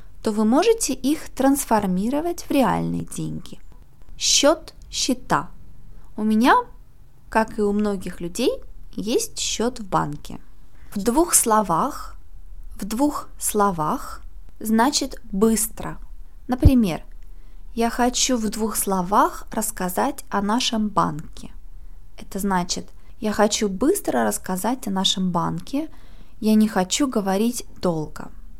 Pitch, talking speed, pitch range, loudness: 220 Hz, 110 wpm, 195-260 Hz, -22 LUFS